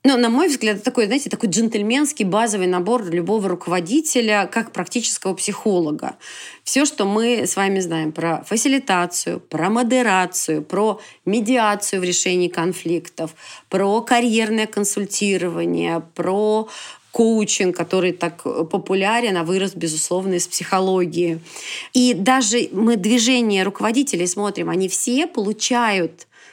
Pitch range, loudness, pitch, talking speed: 180-230 Hz, -19 LUFS, 200 Hz, 120 wpm